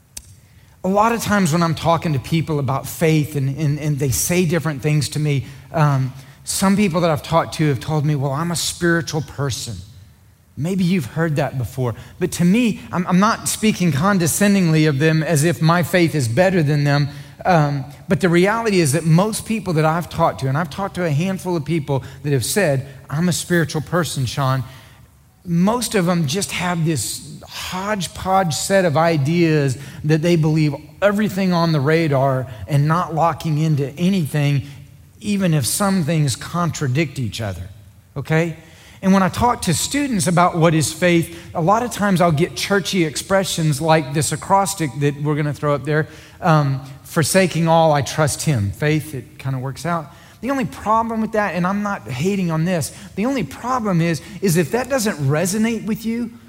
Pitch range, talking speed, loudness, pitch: 140-180 Hz, 190 wpm, -19 LUFS, 160 Hz